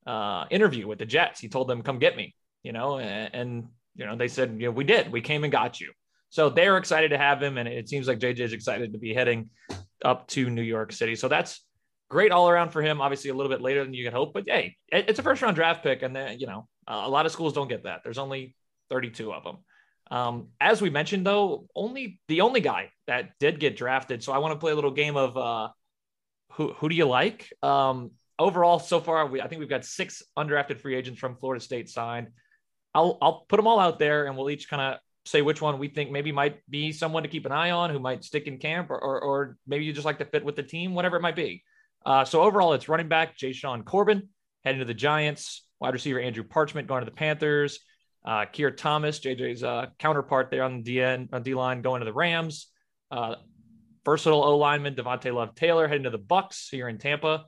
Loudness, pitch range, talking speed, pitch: -26 LUFS, 125-155 Hz, 245 wpm, 140 Hz